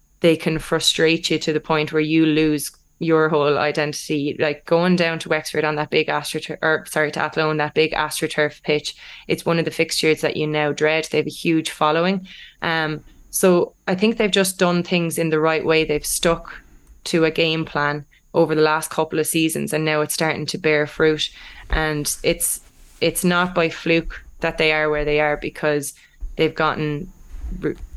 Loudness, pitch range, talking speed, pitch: -20 LUFS, 150-165 Hz, 195 wpm, 155 Hz